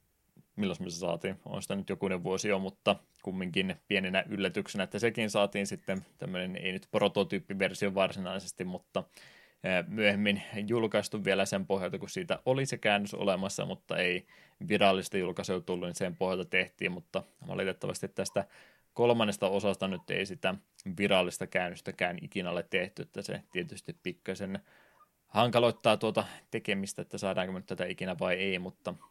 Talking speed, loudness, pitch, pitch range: 145 wpm, -32 LUFS, 100 Hz, 95-105 Hz